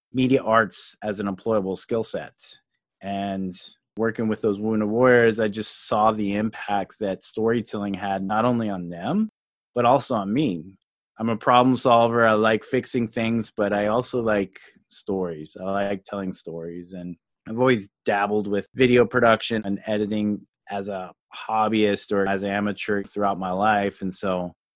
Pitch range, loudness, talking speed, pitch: 100-115 Hz, -23 LUFS, 160 wpm, 105 Hz